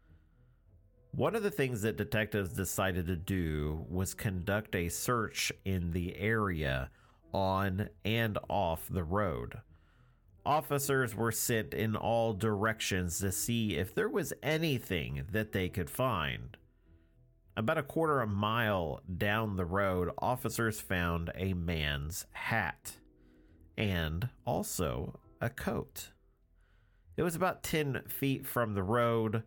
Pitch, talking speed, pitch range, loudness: 100 Hz, 130 wpm, 85-115 Hz, -34 LUFS